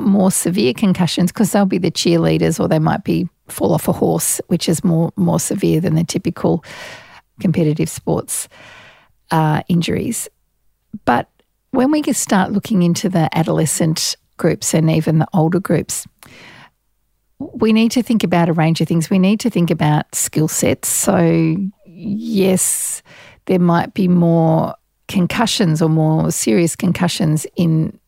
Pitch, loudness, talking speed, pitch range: 175 Hz, -16 LUFS, 150 wpm, 165-195 Hz